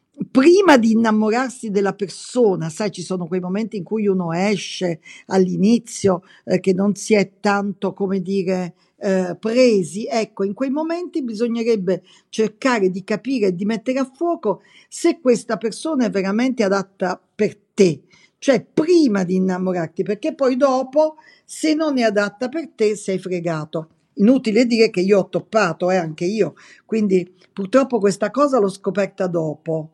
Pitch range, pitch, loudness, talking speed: 185-235 Hz, 200 Hz, -19 LUFS, 155 wpm